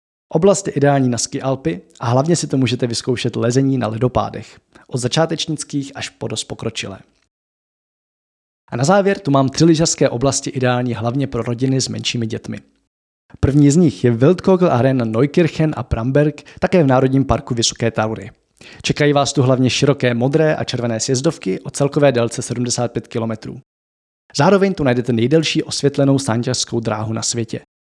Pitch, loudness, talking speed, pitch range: 130 Hz, -17 LUFS, 155 wpm, 115-145 Hz